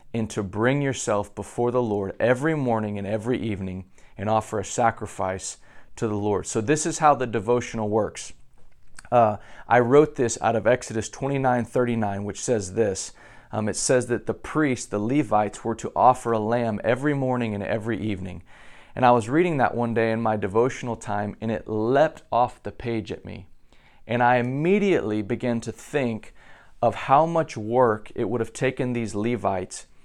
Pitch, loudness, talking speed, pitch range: 115 Hz, -24 LUFS, 180 wpm, 105-125 Hz